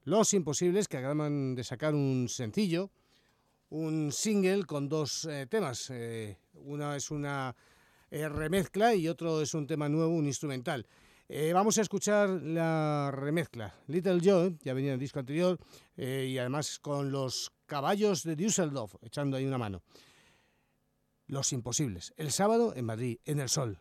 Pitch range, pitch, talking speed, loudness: 130-170 Hz, 150 Hz, 160 wpm, -32 LUFS